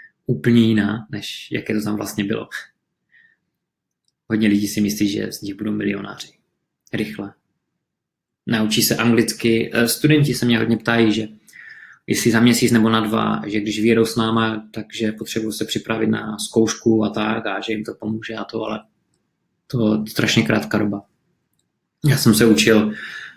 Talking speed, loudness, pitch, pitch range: 160 wpm, -19 LUFS, 110 Hz, 105-115 Hz